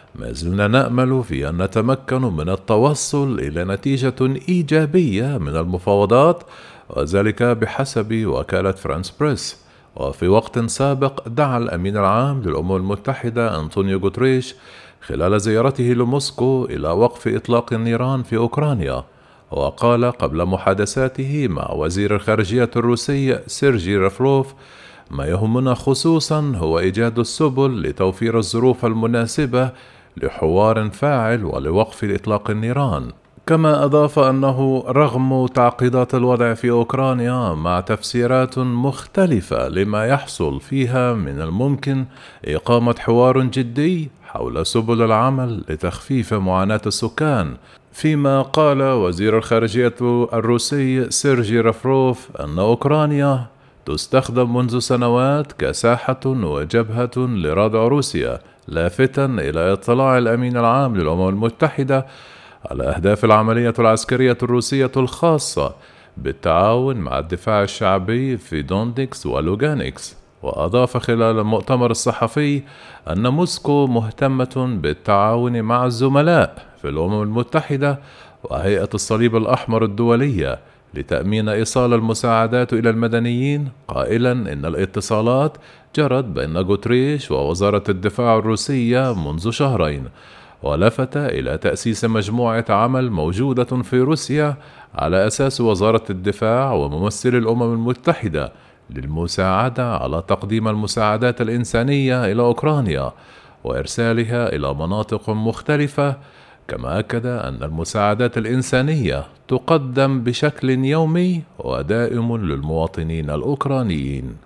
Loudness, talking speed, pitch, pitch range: -18 LUFS, 100 wpm, 120 Hz, 105-130 Hz